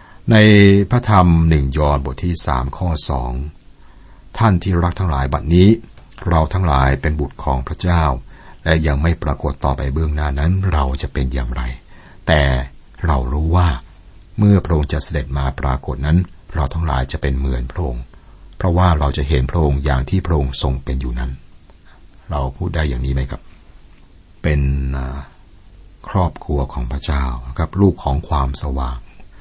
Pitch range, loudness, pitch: 65-90 Hz, -18 LUFS, 75 Hz